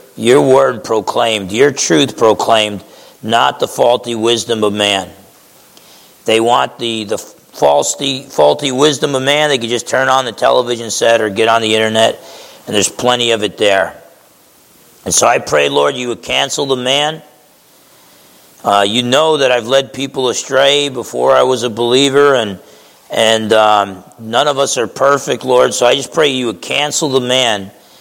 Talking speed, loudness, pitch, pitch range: 175 wpm, -12 LUFS, 120 Hz, 110-135 Hz